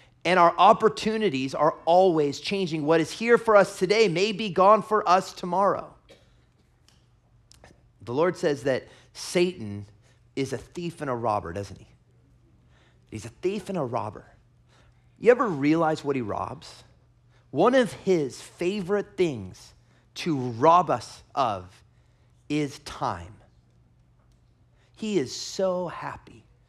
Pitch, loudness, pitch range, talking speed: 150 Hz, -24 LUFS, 120-190 Hz, 130 wpm